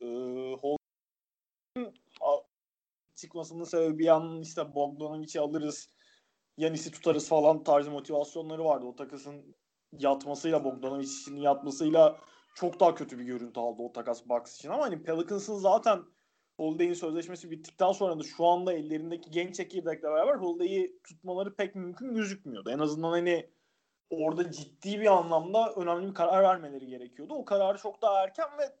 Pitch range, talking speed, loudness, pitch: 145-185 Hz, 145 wpm, -30 LUFS, 165 Hz